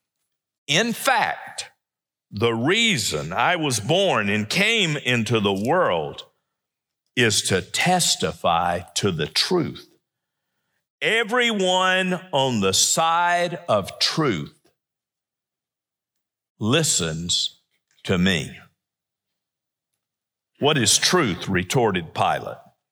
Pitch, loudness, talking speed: 165 Hz, -20 LUFS, 85 wpm